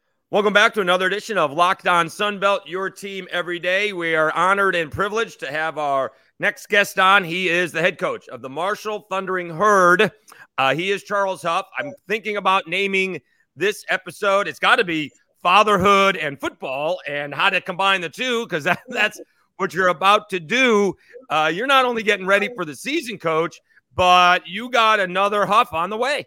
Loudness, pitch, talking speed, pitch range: -19 LUFS, 195 Hz, 190 wpm, 175-210 Hz